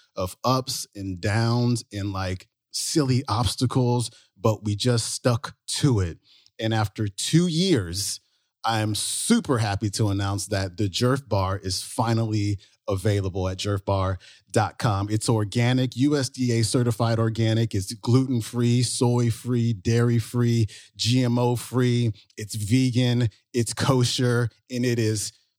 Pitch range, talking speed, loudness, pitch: 105-125 Hz, 125 wpm, -24 LUFS, 115 Hz